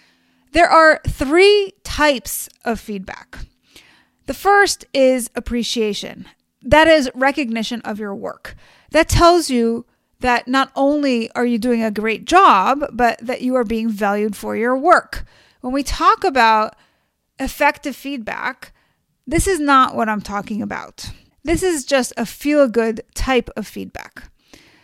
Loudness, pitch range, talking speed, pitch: -17 LUFS, 225-295 Hz, 145 wpm, 255 Hz